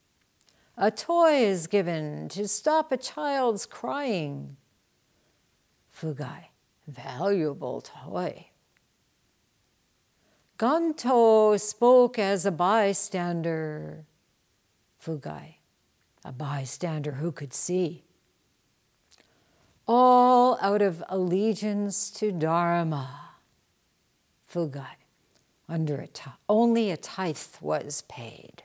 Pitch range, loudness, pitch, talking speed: 150-215 Hz, -26 LUFS, 180 Hz, 80 wpm